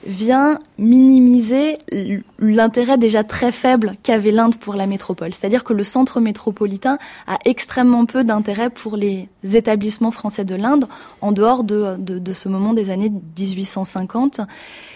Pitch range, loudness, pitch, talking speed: 200-245 Hz, -17 LUFS, 220 Hz, 145 wpm